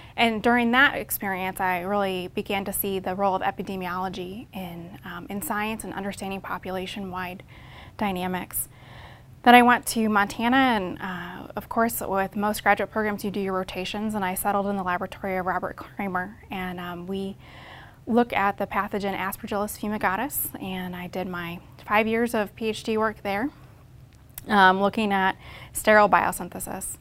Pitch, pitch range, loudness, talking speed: 195 Hz, 185-210 Hz, -25 LUFS, 160 wpm